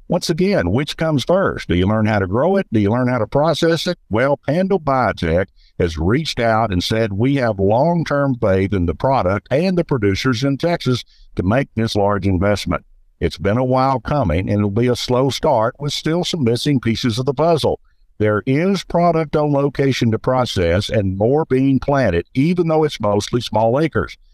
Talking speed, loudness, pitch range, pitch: 200 wpm, -17 LUFS, 105-150 Hz, 130 Hz